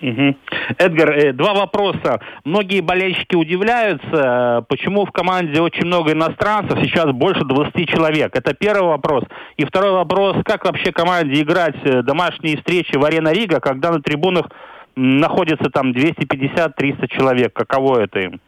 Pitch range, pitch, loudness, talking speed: 140-185 Hz, 165 Hz, -16 LUFS, 135 wpm